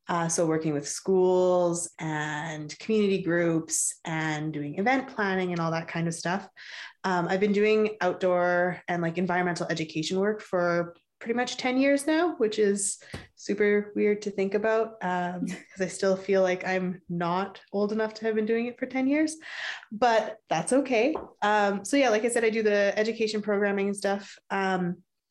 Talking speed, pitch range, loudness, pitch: 180 wpm, 175-215 Hz, -27 LUFS, 195 Hz